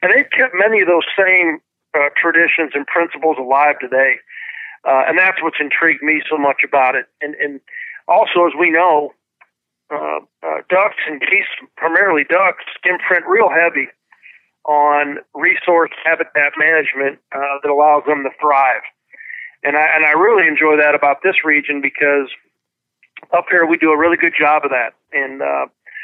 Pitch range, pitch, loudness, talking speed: 145-165 Hz, 150 Hz, -14 LUFS, 165 wpm